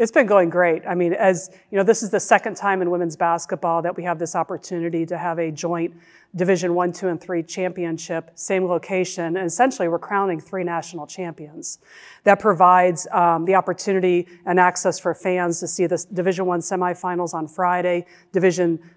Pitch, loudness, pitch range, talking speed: 180 Hz, -21 LUFS, 170-185 Hz, 190 wpm